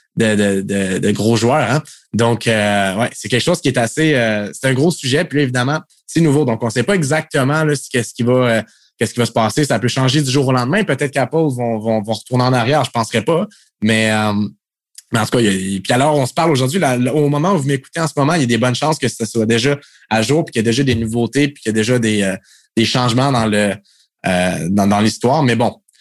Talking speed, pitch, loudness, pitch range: 280 wpm, 125 Hz, -16 LUFS, 110-145 Hz